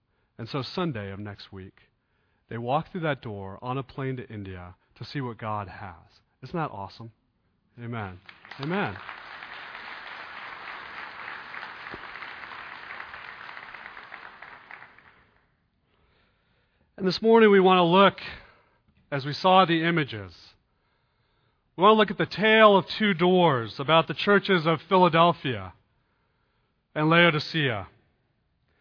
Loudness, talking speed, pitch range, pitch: -23 LUFS, 115 wpm, 105-170 Hz, 130 Hz